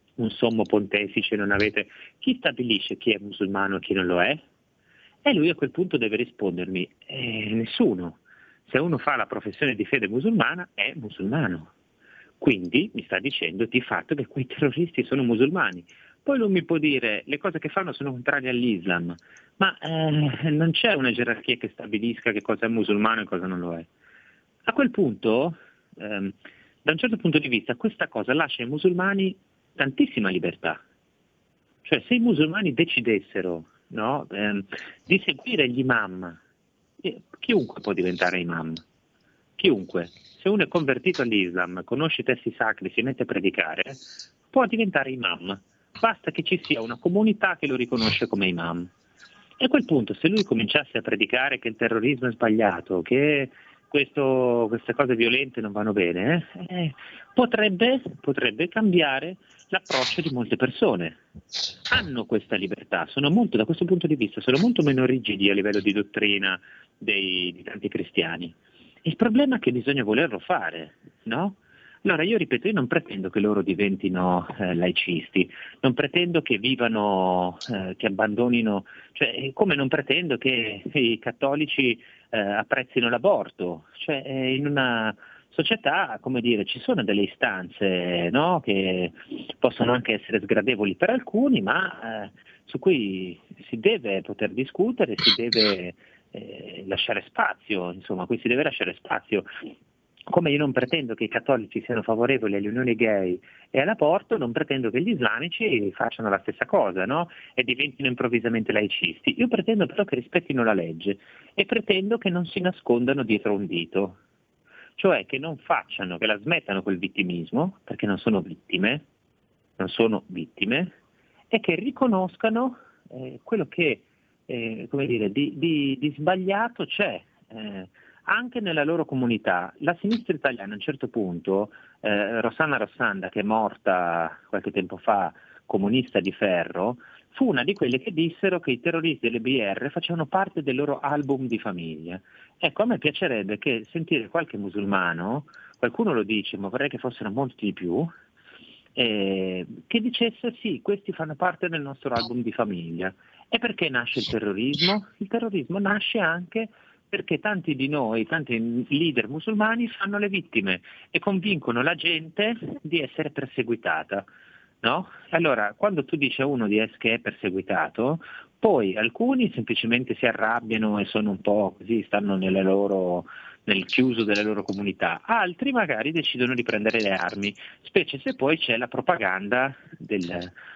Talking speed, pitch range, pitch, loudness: 155 wpm, 105-165 Hz, 125 Hz, -25 LUFS